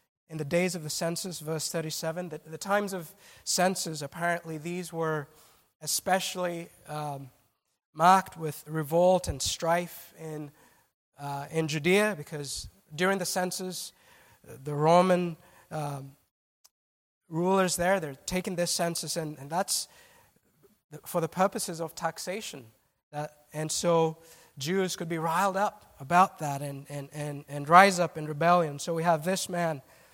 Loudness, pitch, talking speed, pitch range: -28 LUFS, 165 Hz, 140 wpm, 155-180 Hz